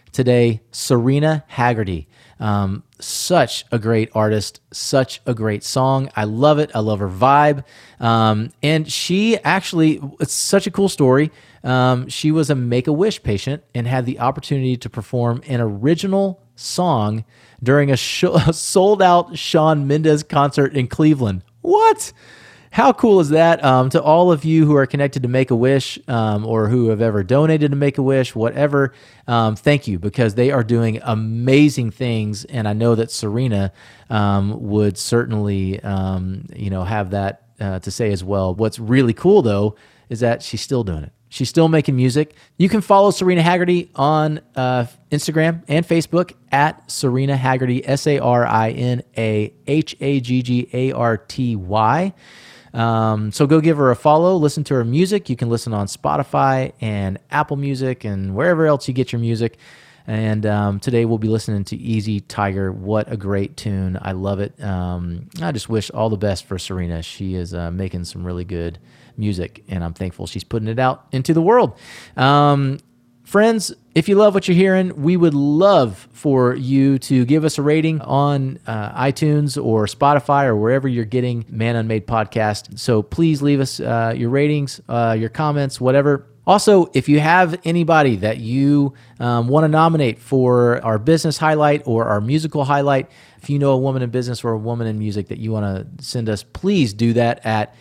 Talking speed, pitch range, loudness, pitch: 185 wpm, 110-150 Hz, -18 LUFS, 125 Hz